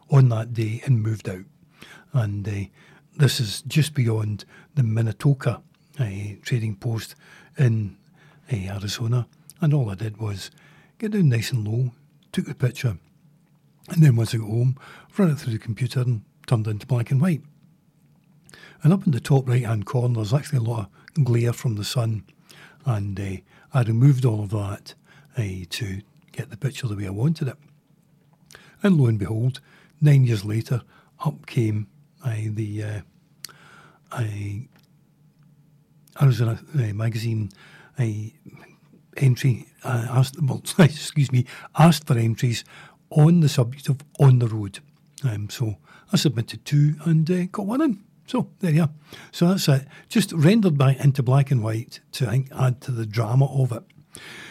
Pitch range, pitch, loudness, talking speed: 115-155 Hz, 135 Hz, -23 LUFS, 170 wpm